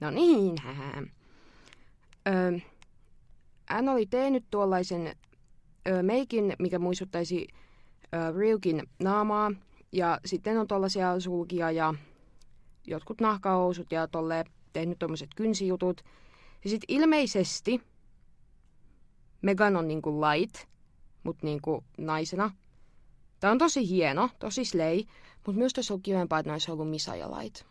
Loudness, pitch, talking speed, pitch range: -29 LUFS, 180 Hz, 115 wpm, 165-210 Hz